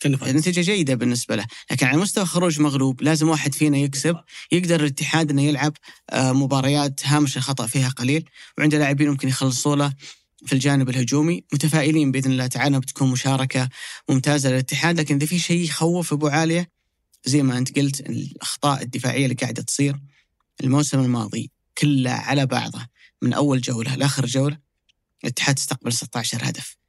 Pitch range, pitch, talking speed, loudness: 130-150 Hz, 140 Hz, 155 wpm, -21 LUFS